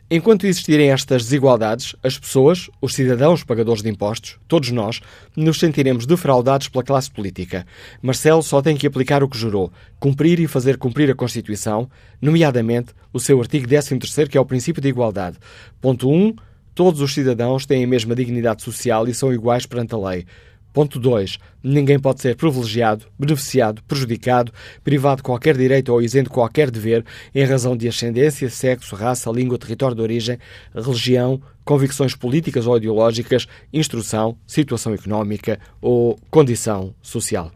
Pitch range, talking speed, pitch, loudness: 115-140 Hz, 160 wpm, 125 Hz, -18 LUFS